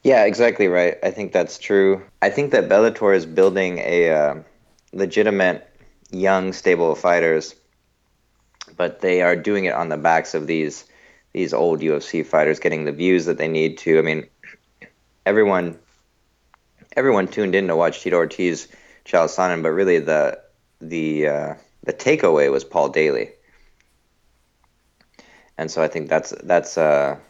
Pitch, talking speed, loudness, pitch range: 90 Hz, 155 wpm, -19 LUFS, 80-100 Hz